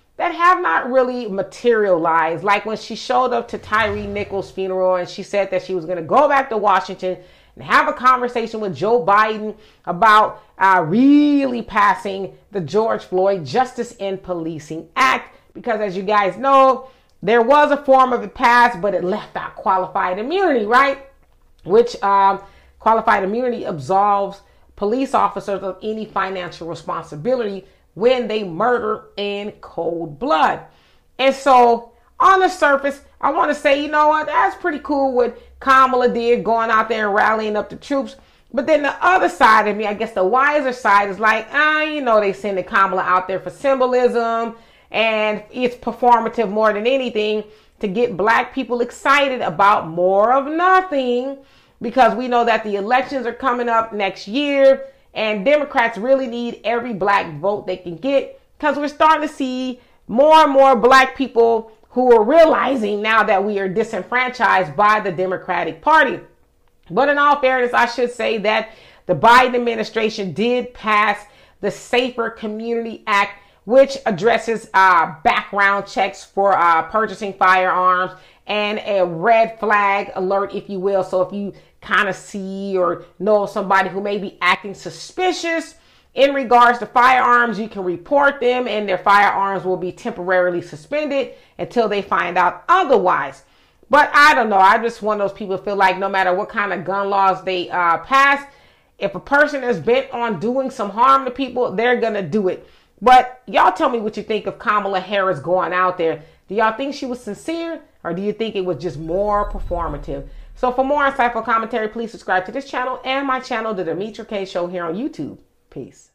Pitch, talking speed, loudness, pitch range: 220 Hz, 175 wpm, -17 LUFS, 195-255 Hz